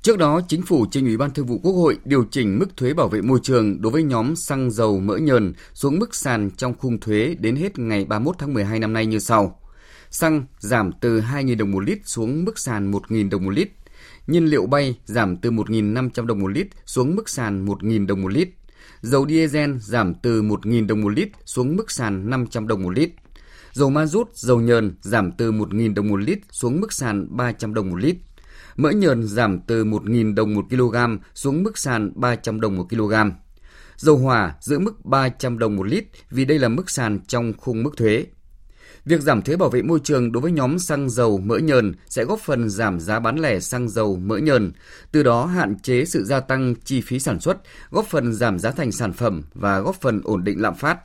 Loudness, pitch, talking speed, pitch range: -21 LUFS, 120 Hz, 220 wpm, 105-140 Hz